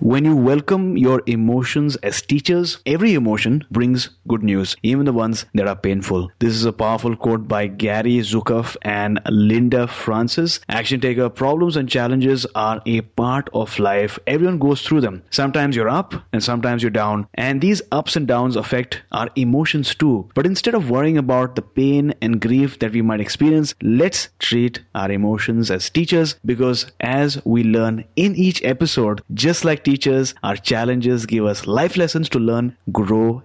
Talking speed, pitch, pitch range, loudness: 175 wpm, 120 Hz, 110-140 Hz, -18 LUFS